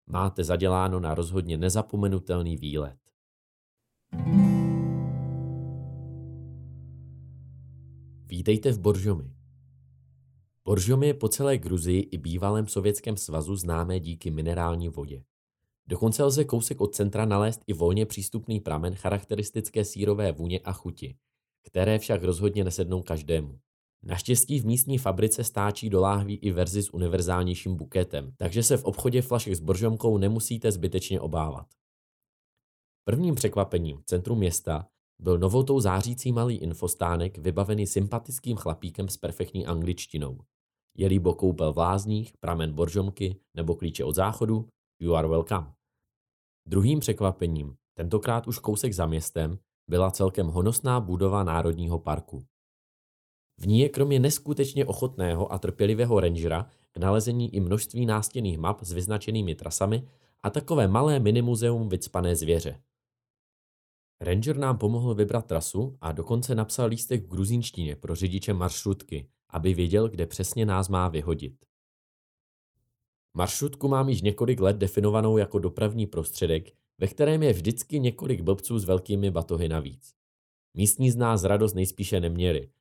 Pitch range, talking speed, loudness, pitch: 85-110 Hz, 130 wpm, -27 LUFS, 95 Hz